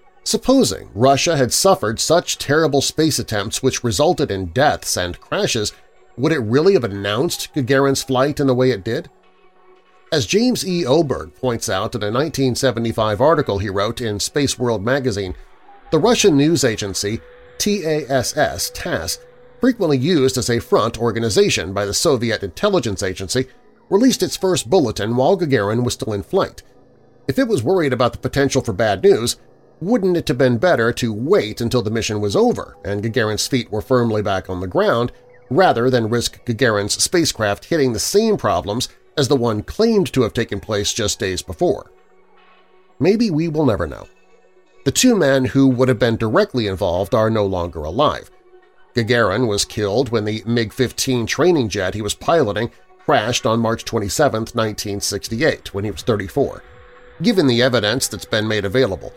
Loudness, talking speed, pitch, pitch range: -18 LUFS, 165 wpm, 120 Hz, 105-145 Hz